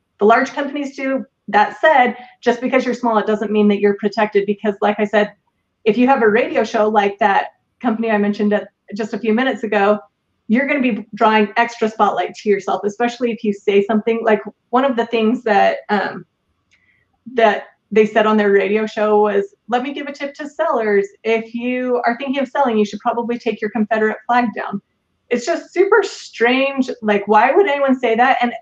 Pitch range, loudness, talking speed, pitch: 210-250 Hz, -17 LUFS, 205 wpm, 225 Hz